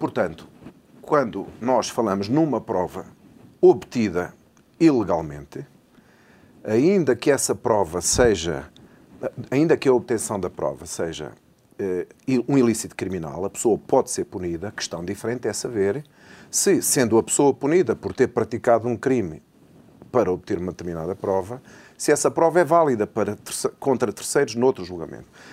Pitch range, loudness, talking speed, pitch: 95-135 Hz, -22 LUFS, 135 wpm, 115 Hz